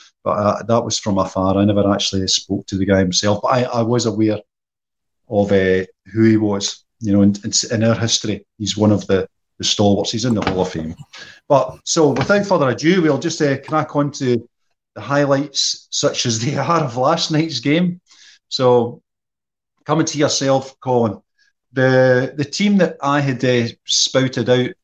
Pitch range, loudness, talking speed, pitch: 105-145 Hz, -17 LUFS, 185 wpm, 120 Hz